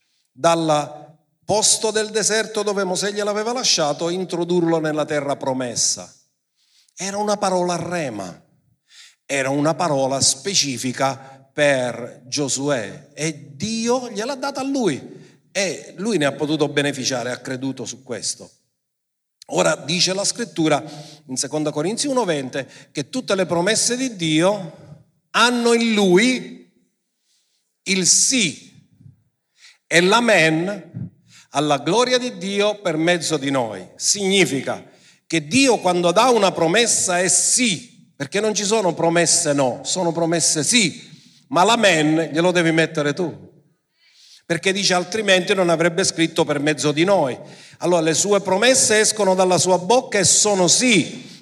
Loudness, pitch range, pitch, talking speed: -18 LUFS, 150-205 Hz, 175 Hz, 130 wpm